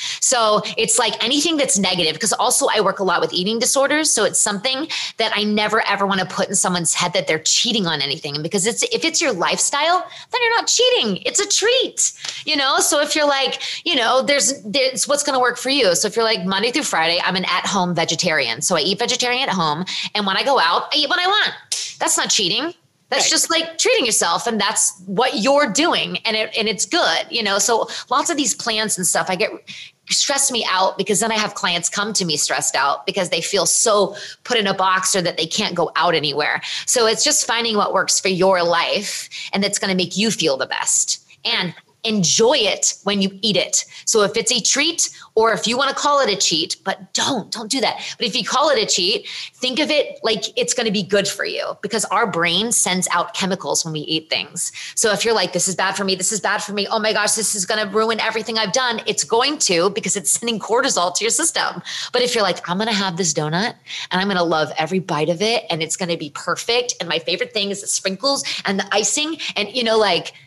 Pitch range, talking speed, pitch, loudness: 190-255 Hz, 250 wpm, 215 Hz, -18 LUFS